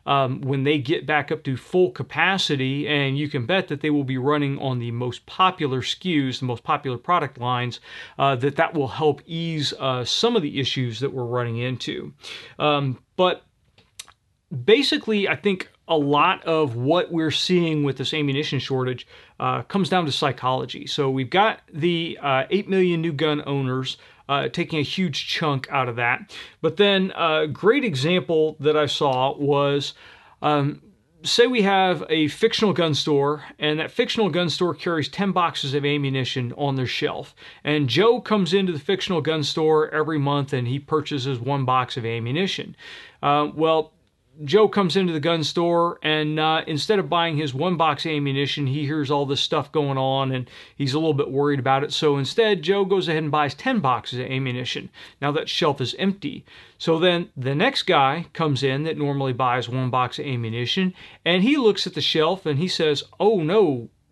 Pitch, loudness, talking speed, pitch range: 150 Hz, -22 LUFS, 190 wpm, 135-170 Hz